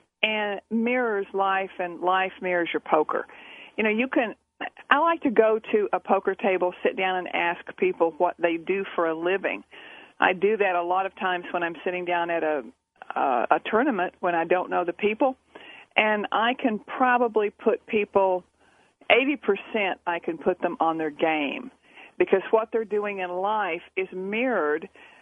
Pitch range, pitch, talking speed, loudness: 180-225 Hz, 195 Hz, 180 wpm, -25 LUFS